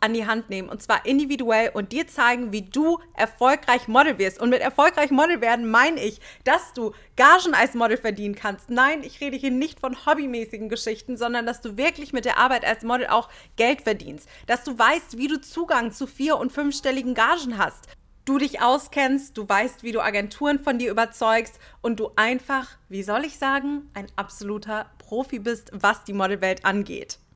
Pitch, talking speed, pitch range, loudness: 240 Hz, 190 wpm, 220-275 Hz, -22 LUFS